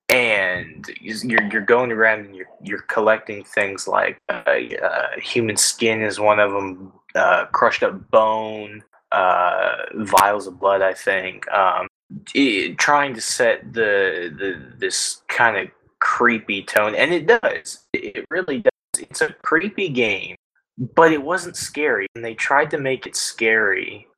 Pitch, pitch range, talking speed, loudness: 110 Hz, 105-130 Hz, 155 wpm, -19 LUFS